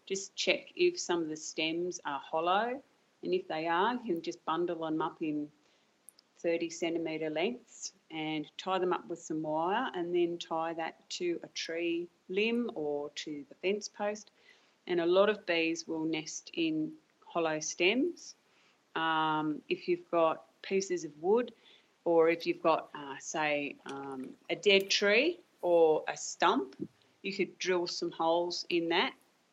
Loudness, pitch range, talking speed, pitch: -33 LUFS, 160-200 Hz, 165 wpm, 170 Hz